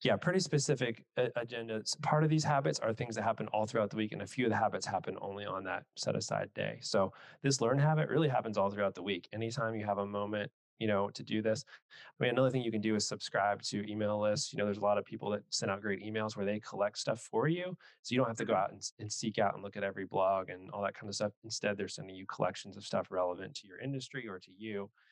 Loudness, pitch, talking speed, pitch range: -35 LUFS, 110 Hz, 275 wpm, 100-125 Hz